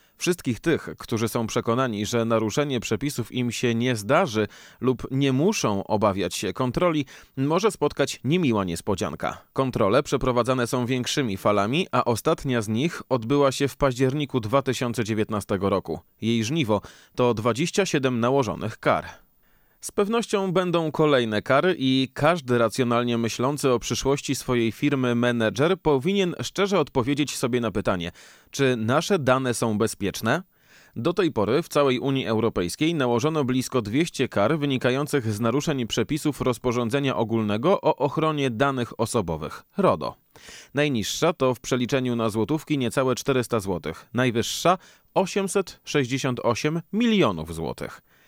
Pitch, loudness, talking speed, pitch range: 130 Hz, -24 LUFS, 130 wpm, 115-145 Hz